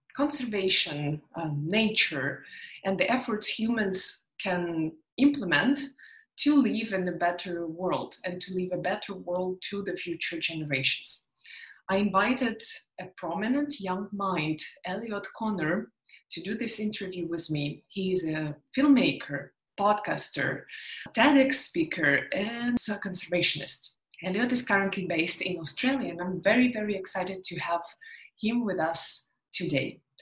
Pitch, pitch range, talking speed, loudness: 195 Hz, 175-235 Hz, 130 wpm, -28 LUFS